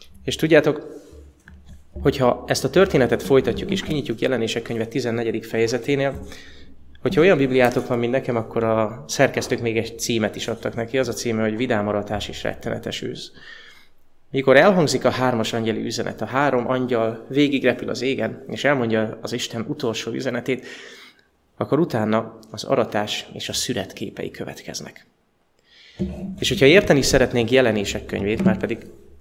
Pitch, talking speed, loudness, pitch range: 115 Hz, 145 wpm, -21 LUFS, 110-130 Hz